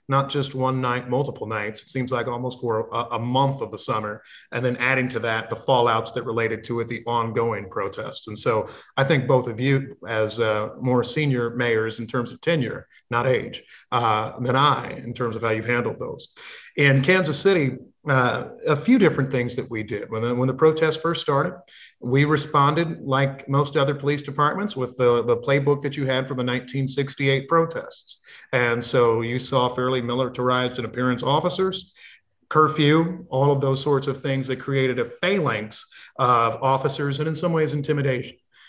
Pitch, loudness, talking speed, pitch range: 130 Hz, -23 LUFS, 190 wpm, 120-145 Hz